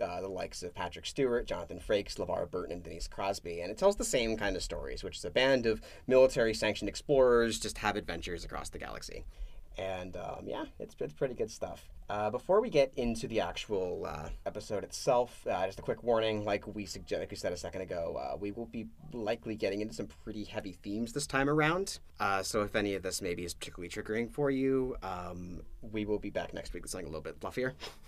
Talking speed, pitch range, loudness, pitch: 220 wpm, 95-125 Hz, -34 LUFS, 105 Hz